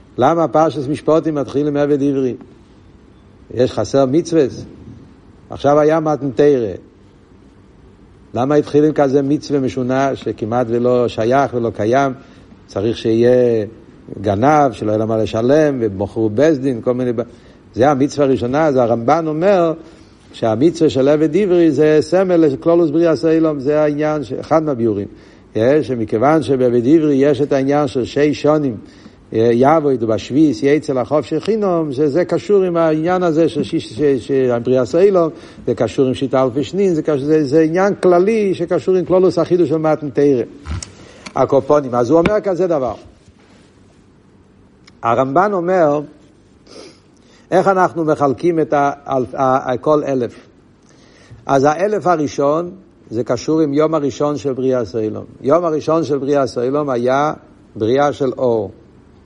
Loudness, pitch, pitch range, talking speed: -15 LUFS, 145 Hz, 125-160 Hz, 130 wpm